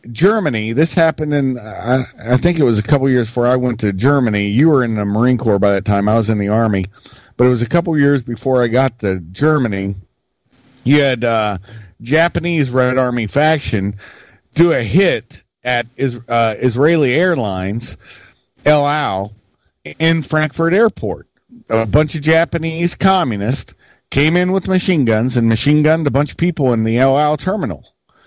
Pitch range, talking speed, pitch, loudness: 110-155 Hz, 180 wpm, 125 Hz, -15 LUFS